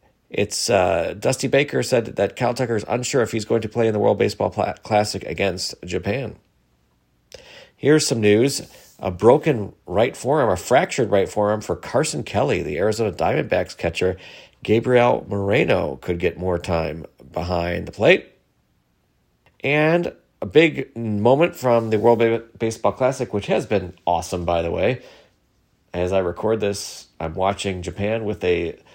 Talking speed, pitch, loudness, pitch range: 160 wpm, 105 Hz, -21 LUFS, 90-115 Hz